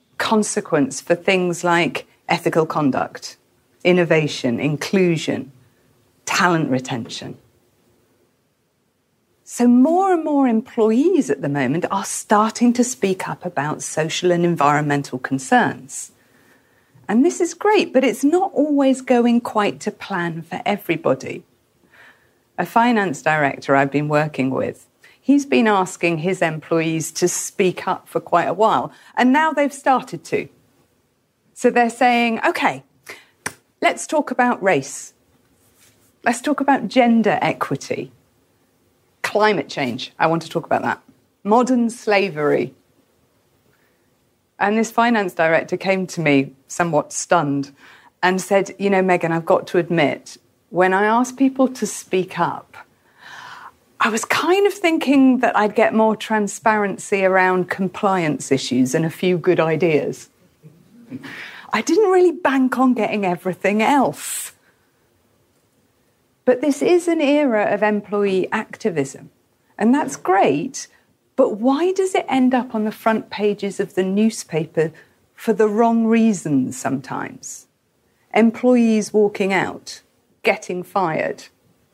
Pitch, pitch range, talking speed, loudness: 195 Hz, 160-240 Hz, 125 wpm, -19 LUFS